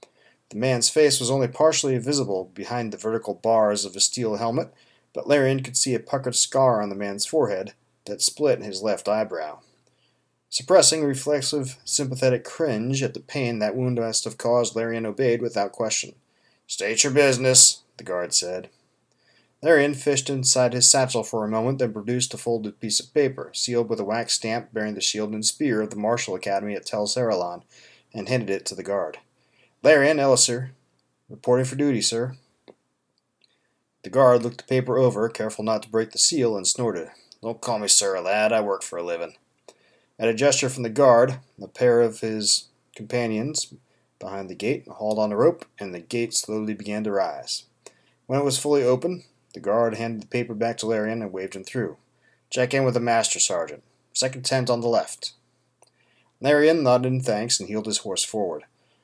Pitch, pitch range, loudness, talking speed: 120 Hz, 110-130 Hz, -22 LUFS, 185 wpm